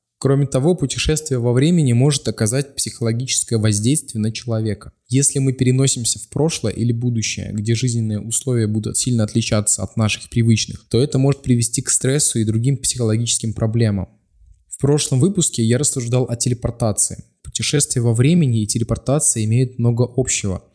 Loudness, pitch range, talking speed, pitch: -18 LUFS, 110-135 Hz, 150 wpm, 120 Hz